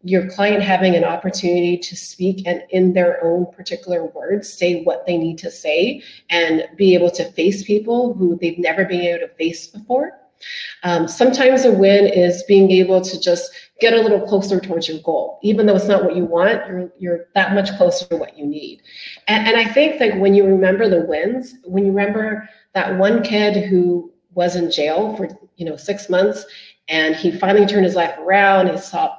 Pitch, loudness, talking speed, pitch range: 185 Hz, -16 LUFS, 205 wpm, 175-205 Hz